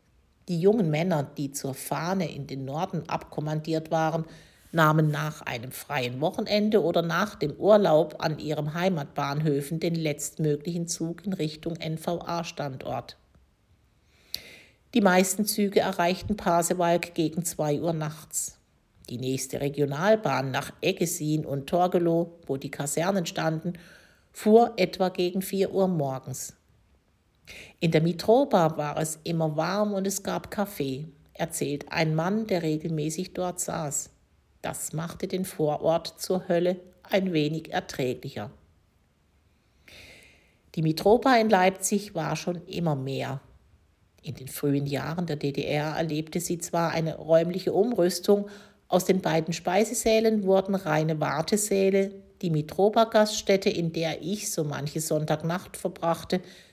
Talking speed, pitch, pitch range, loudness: 125 wpm, 165 Hz, 150-185 Hz, -27 LUFS